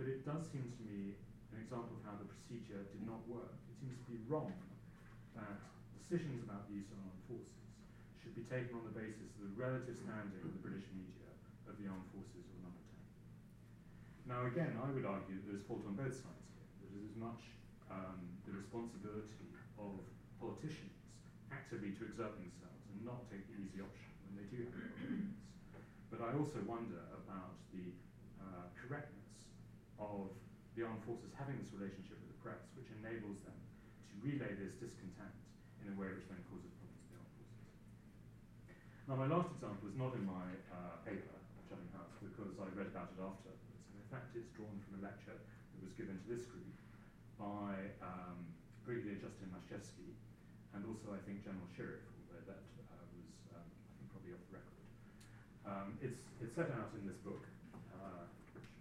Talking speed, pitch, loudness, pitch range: 185 wpm, 105 Hz, -50 LUFS, 95-115 Hz